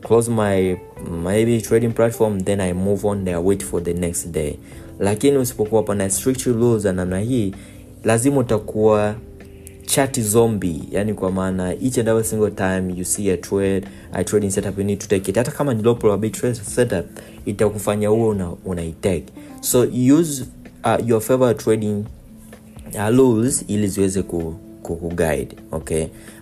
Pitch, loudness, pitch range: 105 Hz, -20 LUFS, 95-115 Hz